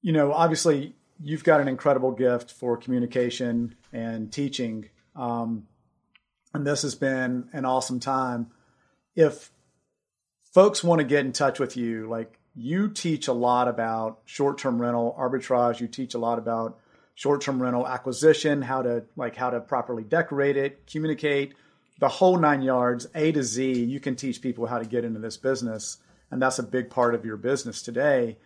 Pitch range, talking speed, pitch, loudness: 120-140 Hz, 170 wpm, 125 Hz, -25 LUFS